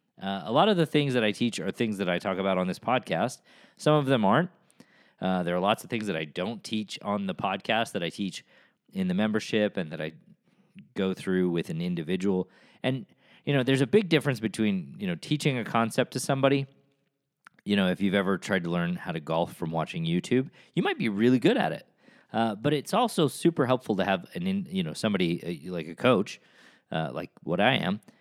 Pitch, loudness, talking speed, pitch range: 130 Hz, -28 LUFS, 230 wpm, 100-165 Hz